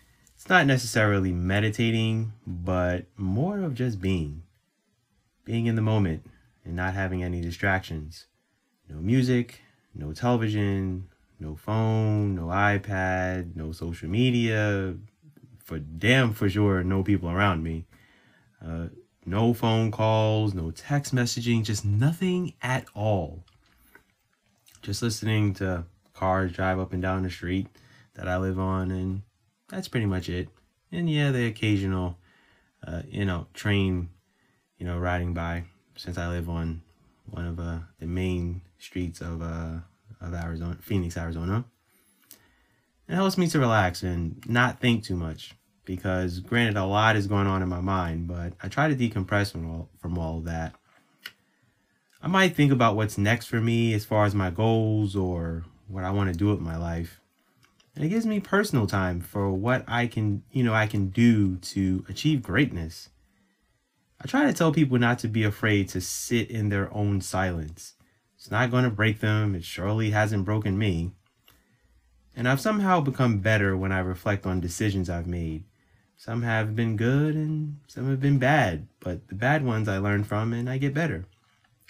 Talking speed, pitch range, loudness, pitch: 165 wpm, 90-115 Hz, -26 LUFS, 100 Hz